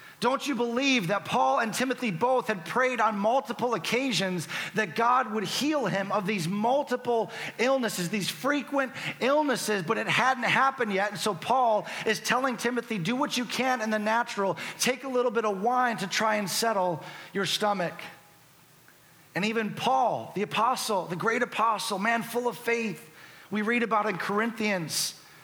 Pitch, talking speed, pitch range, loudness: 220 Hz, 170 wpm, 195-245 Hz, -27 LUFS